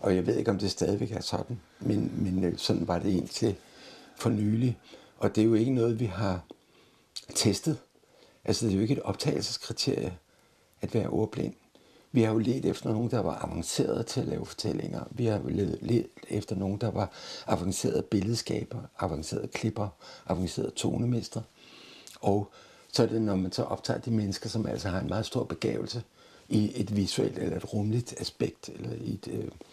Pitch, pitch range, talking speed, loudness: 110 Hz, 100-115 Hz, 185 wpm, -30 LUFS